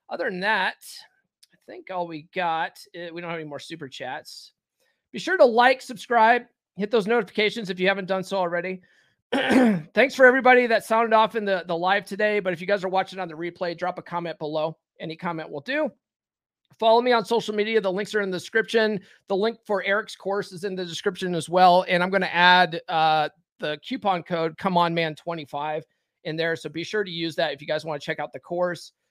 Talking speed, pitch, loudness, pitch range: 225 wpm, 185 Hz, -23 LUFS, 170-215 Hz